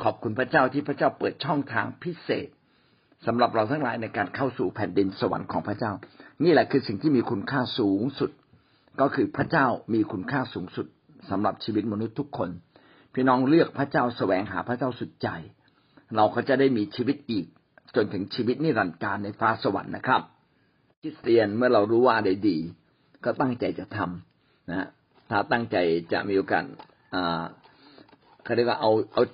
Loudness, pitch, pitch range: -26 LUFS, 115 Hz, 100-130 Hz